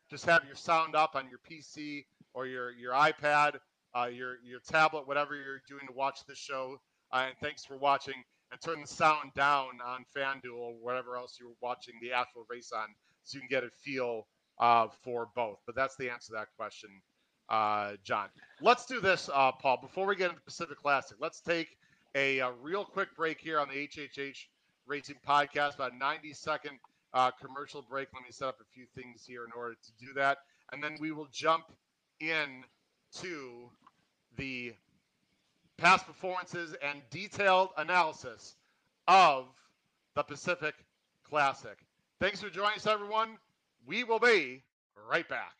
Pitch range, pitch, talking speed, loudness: 125-155 Hz, 140 Hz, 175 wpm, -32 LUFS